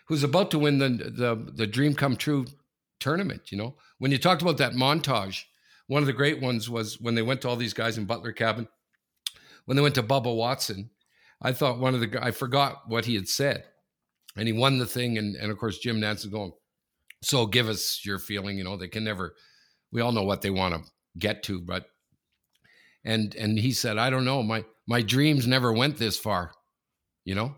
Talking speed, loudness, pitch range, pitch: 220 wpm, -27 LUFS, 105-135 Hz, 115 Hz